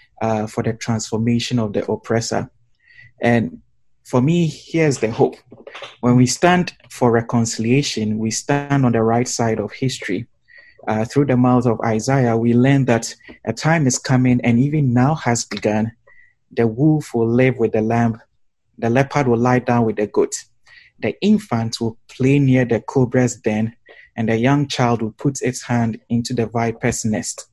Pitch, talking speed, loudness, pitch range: 120 Hz, 170 wpm, -18 LUFS, 115-135 Hz